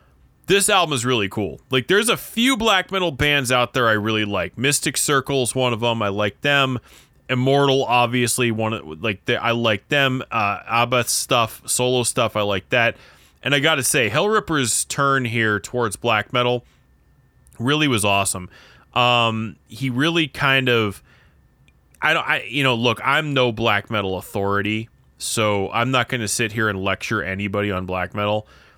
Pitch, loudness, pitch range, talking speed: 120 Hz, -19 LUFS, 105-135 Hz, 175 wpm